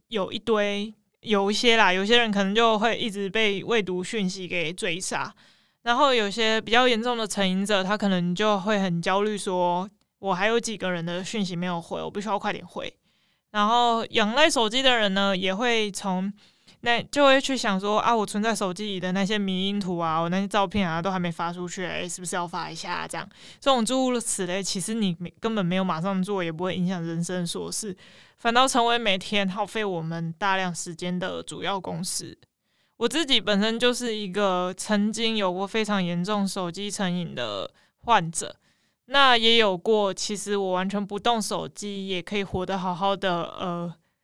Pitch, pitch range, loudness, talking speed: 200 Hz, 185-220 Hz, -25 LUFS, 285 characters per minute